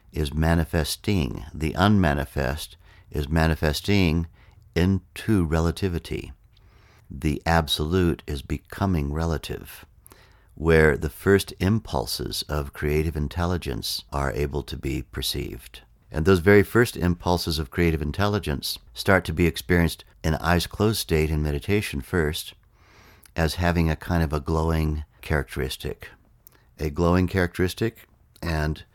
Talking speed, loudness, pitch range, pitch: 115 wpm, -24 LUFS, 75-95 Hz, 85 Hz